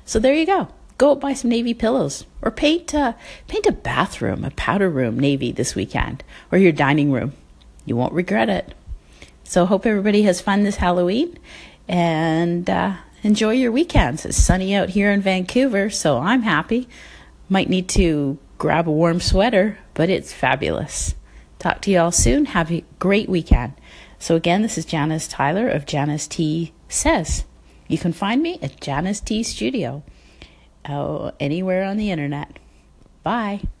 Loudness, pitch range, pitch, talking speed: -20 LUFS, 150-215 Hz, 180 Hz, 165 wpm